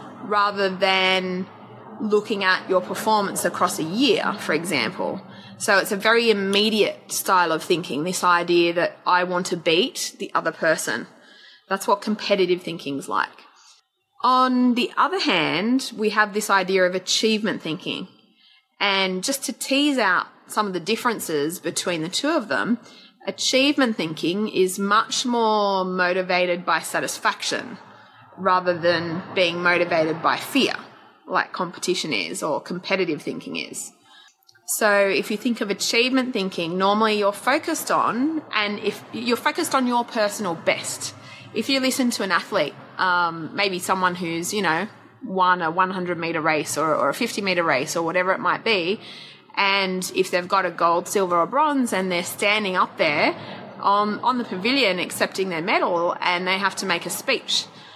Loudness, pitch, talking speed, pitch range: -22 LUFS, 195 Hz, 160 wpm, 180-225 Hz